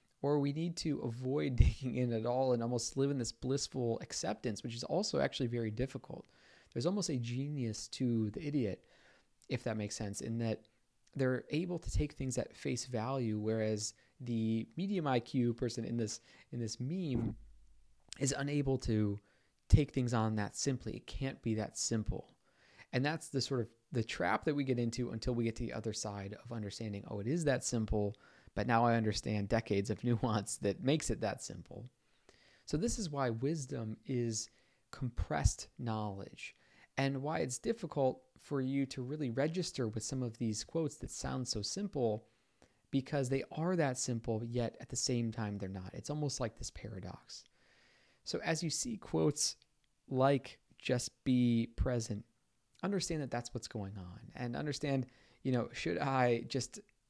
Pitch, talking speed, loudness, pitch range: 125 Hz, 175 wpm, -37 LUFS, 110-135 Hz